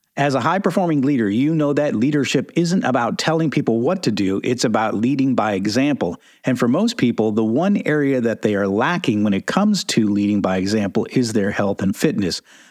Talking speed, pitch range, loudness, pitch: 210 wpm, 110-180 Hz, -19 LUFS, 145 Hz